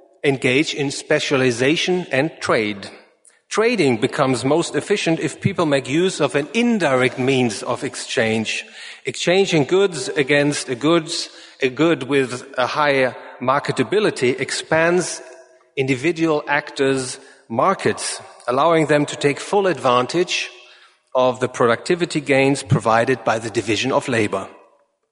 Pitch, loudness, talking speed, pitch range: 140 Hz, -19 LUFS, 120 wpm, 130-165 Hz